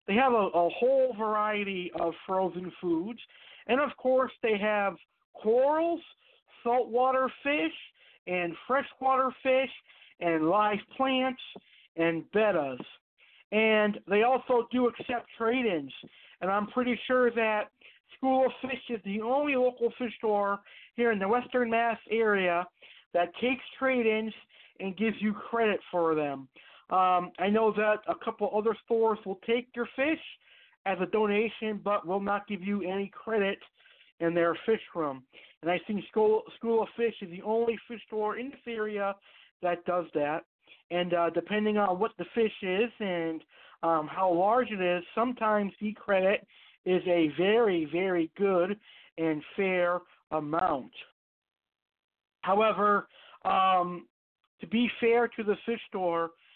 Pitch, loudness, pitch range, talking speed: 210 Hz, -29 LUFS, 180-235 Hz, 150 wpm